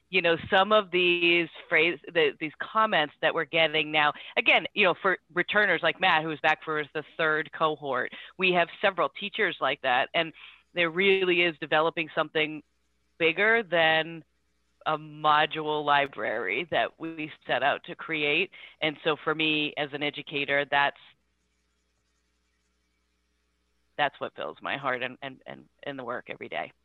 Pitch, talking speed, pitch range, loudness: 155 Hz, 155 wpm, 140-170 Hz, -26 LUFS